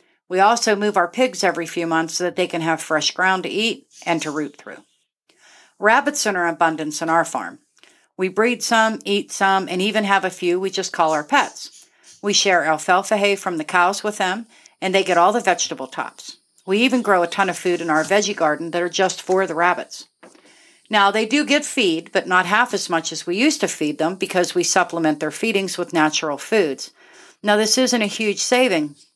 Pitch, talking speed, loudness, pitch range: 185 Hz, 220 wpm, -19 LUFS, 170-210 Hz